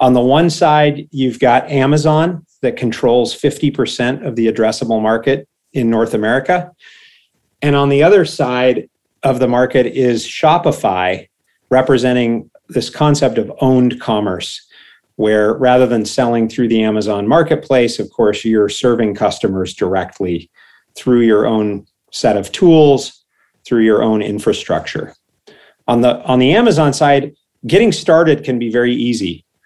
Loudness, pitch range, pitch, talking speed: -14 LUFS, 115-145 Hz, 125 Hz, 140 wpm